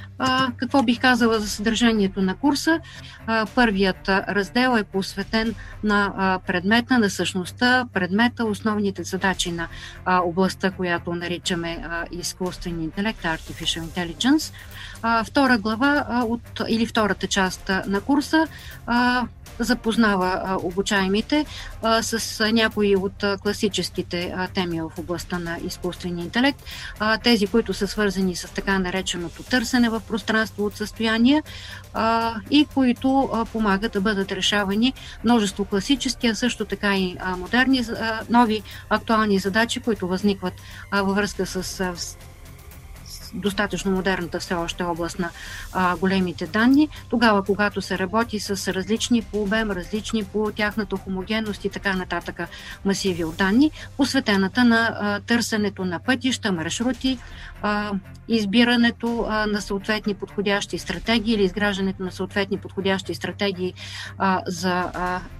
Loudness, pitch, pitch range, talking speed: -22 LUFS, 205 Hz, 185-225 Hz, 135 wpm